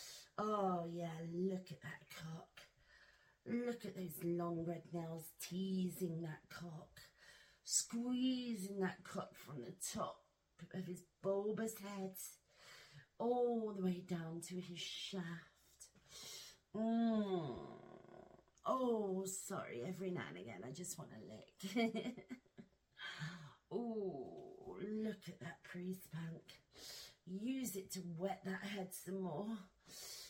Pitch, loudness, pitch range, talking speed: 185 Hz, -45 LUFS, 170-210 Hz, 115 wpm